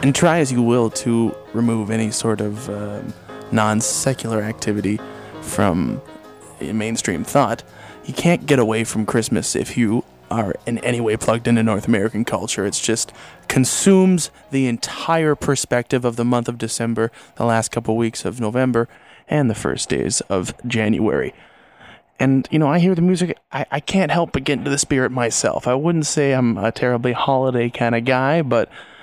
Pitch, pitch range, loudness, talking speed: 120 Hz, 110-135 Hz, -19 LUFS, 180 wpm